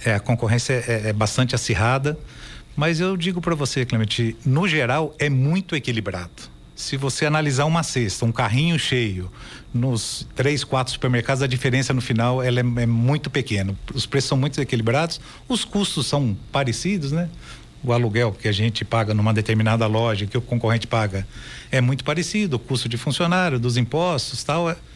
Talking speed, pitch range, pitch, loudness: 175 wpm, 115-145 Hz, 130 Hz, -22 LUFS